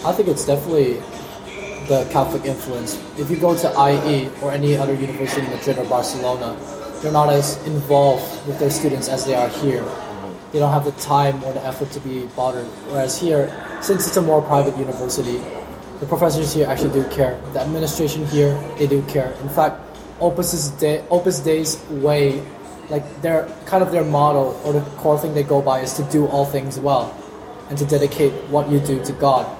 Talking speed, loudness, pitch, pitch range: 195 wpm, -19 LUFS, 145 Hz, 135-155 Hz